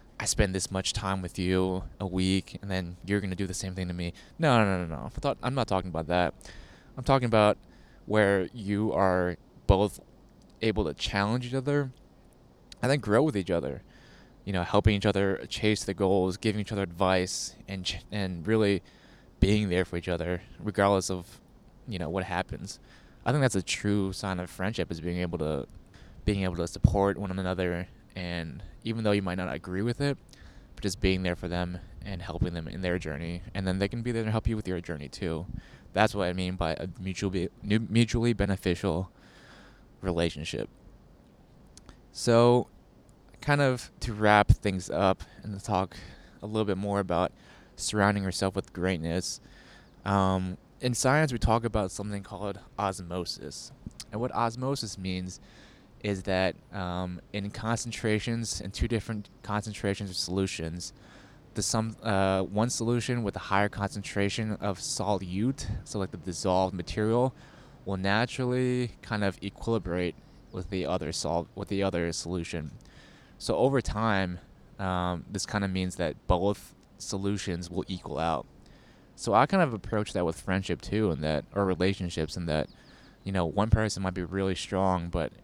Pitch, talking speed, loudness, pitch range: 95 Hz, 170 wpm, -29 LUFS, 90-105 Hz